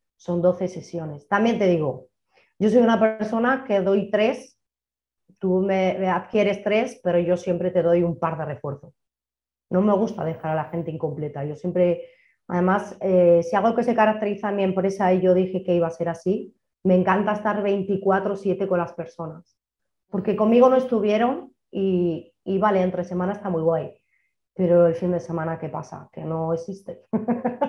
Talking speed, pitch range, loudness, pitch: 180 wpm, 170-205 Hz, -22 LUFS, 185 Hz